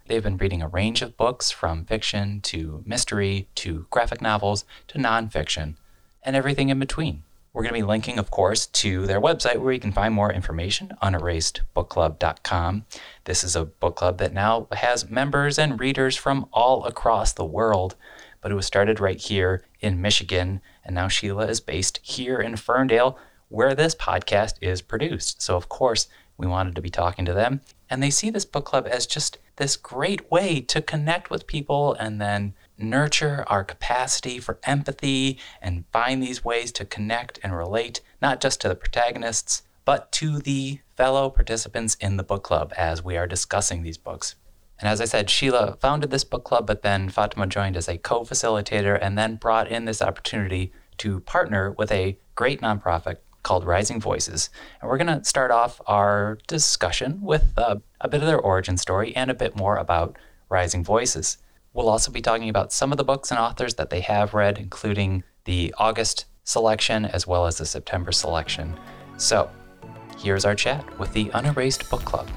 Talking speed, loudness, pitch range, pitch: 185 wpm, -24 LUFS, 95-125 Hz, 105 Hz